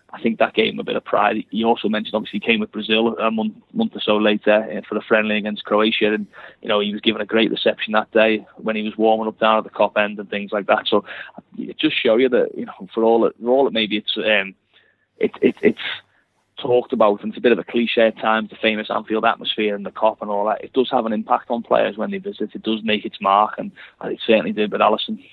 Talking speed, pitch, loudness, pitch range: 270 wpm, 110 Hz, -19 LUFS, 105-115 Hz